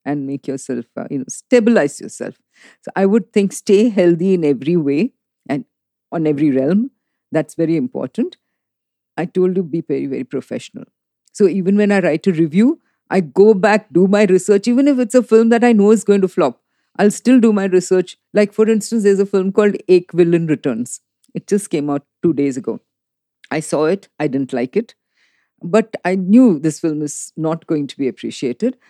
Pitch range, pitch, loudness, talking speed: 155-215 Hz, 190 Hz, -16 LUFS, 195 wpm